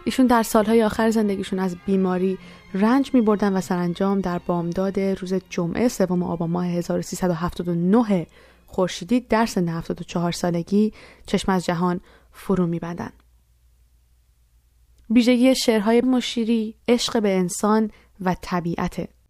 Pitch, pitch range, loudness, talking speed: 190 Hz, 175-220 Hz, -22 LUFS, 120 wpm